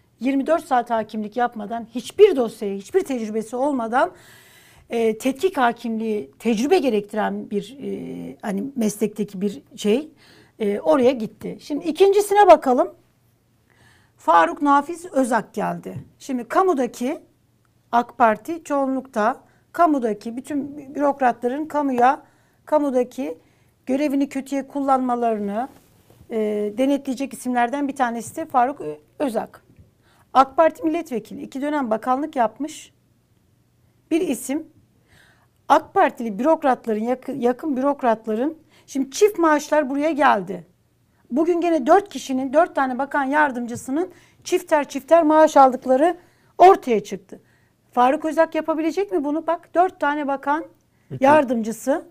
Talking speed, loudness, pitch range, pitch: 110 wpm, -21 LUFS, 230-305 Hz, 270 Hz